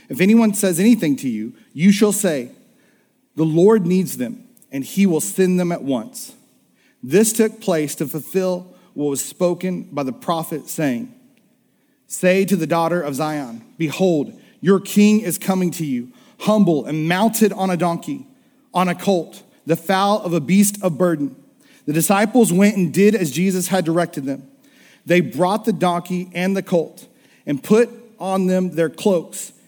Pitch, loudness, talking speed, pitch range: 185 Hz, -18 LUFS, 170 wpm, 170-220 Hz